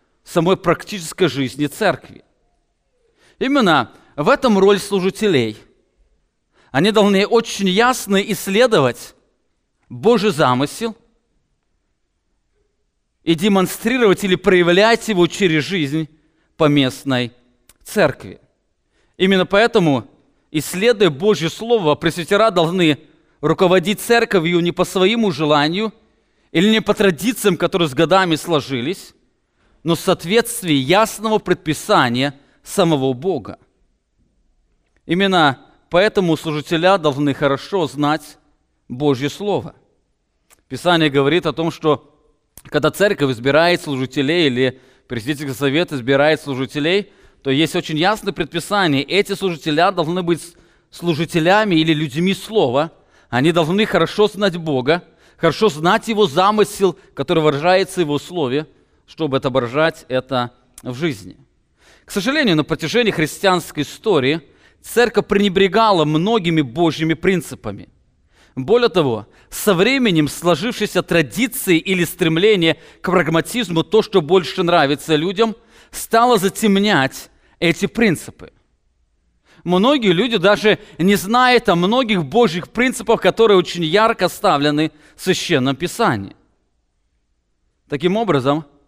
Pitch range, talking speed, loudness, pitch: 150-200 Hz, 105 wpm, -17 LUFS, 170 Hz